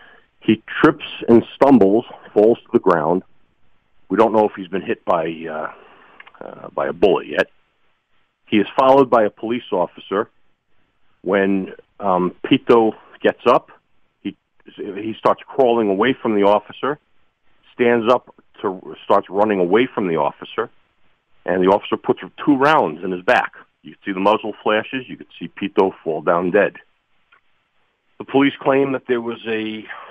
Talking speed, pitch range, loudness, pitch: 155 wpm, 100-125 Hz, -18 LUFS, 110 Hz